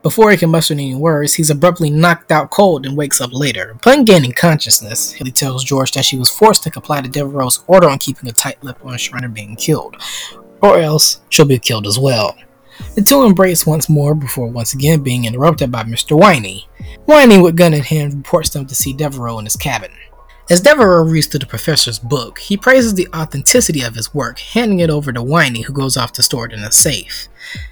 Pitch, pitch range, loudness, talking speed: 145 Hz, 125-170 Hz, -12 LUFS, 215 wpm